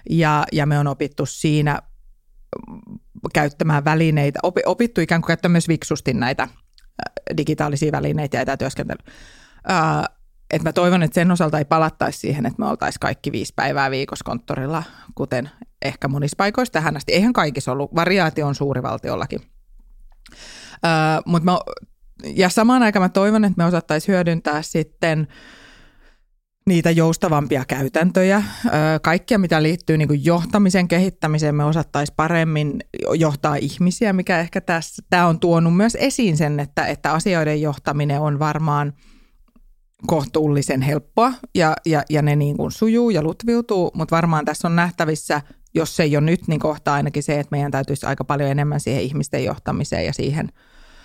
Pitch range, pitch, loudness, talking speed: 145-175 Hz, 155 Hz, -19 LUFS, 145 wpm